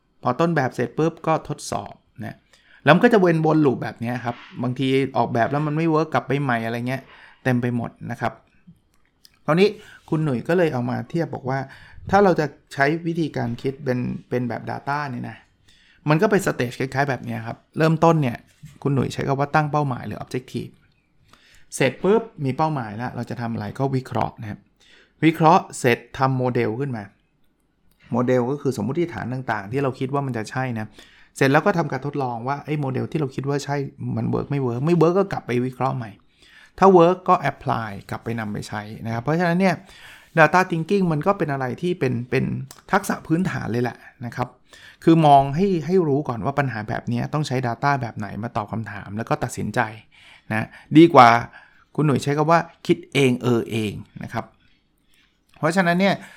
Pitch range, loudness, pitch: 120-155 Hz, -22 LUFS, 135 Hz